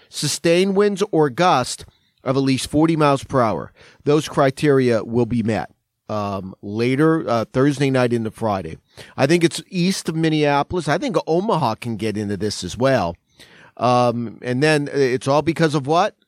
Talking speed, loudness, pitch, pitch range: 170 wpm, -19 LUFS, 135 Hz, 110-155 Hz